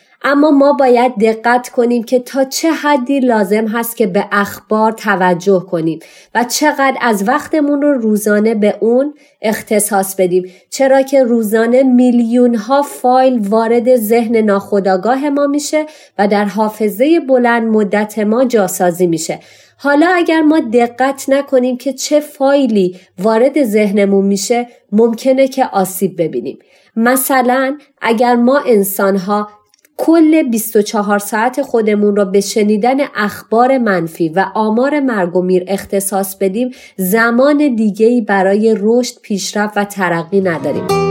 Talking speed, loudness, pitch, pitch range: 130 wpm, -13 LUFS, 230 Hz, 205-265 Hz